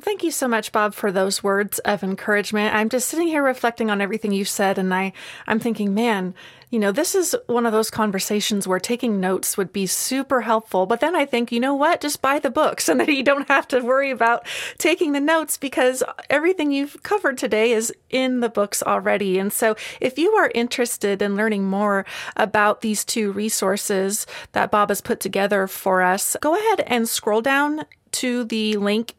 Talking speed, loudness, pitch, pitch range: 205 wpm, -21 LUFS, 225 Hz, 205-275 Hz